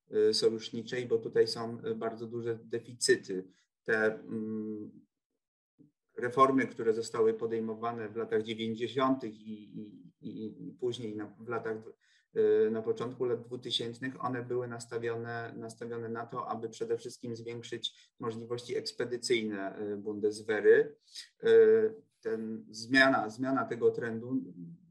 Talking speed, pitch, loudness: 110 wpm, 120 Hz, -32 LUFS